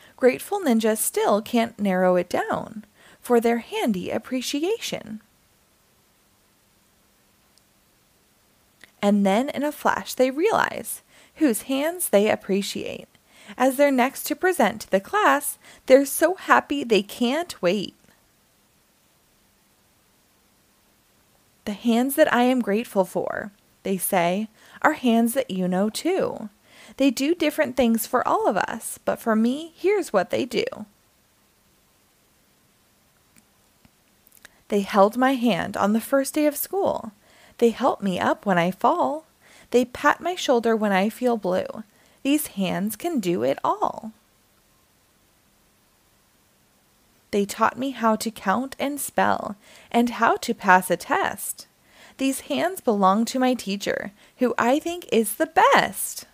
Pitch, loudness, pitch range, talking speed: 240 Hz, -23 LUFS, 210-280 Hz, 130 wpm